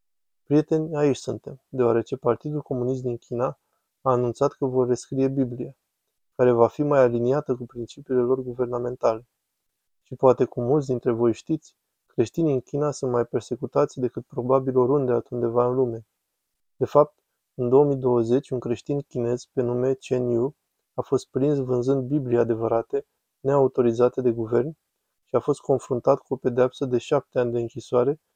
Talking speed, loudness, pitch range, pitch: 155 wpm, -24 LUFS, 120-140 Hz, 130 Hz